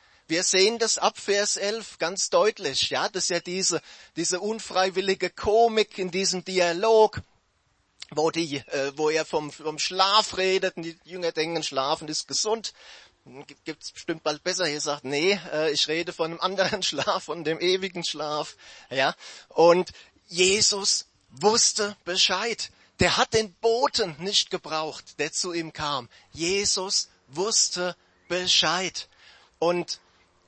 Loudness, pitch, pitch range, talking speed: -24 LUFS, 180 Hz, 155-195 Hz, 145 wpm